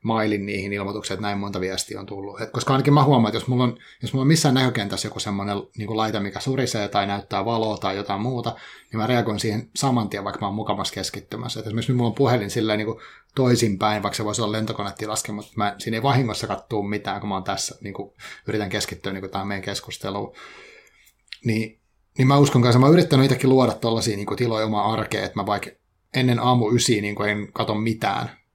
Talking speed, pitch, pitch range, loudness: 210 wpm, 110 Hz, 100-120 Hz, -23 LUFS